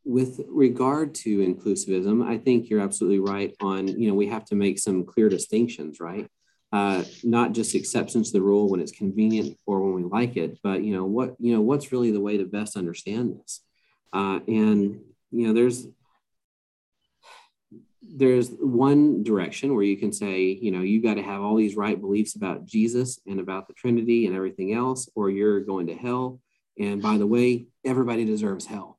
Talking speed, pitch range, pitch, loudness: 190 wpm, 95-120 Hz, 105 Hz, -24 LUFS